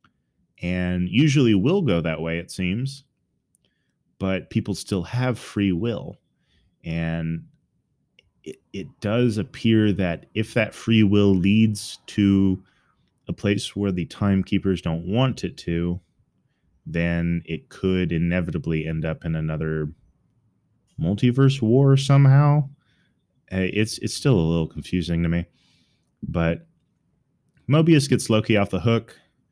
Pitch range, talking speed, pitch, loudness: 85-120 Hz, 125 wpm, 100 Hz, -22 LUFS